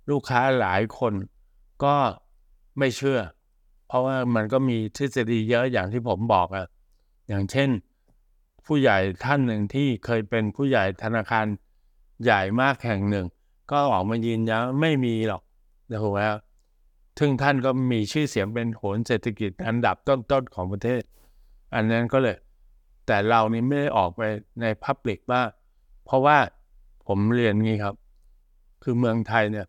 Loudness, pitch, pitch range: -24 LUFS, 115 Hz, 100-130 Hz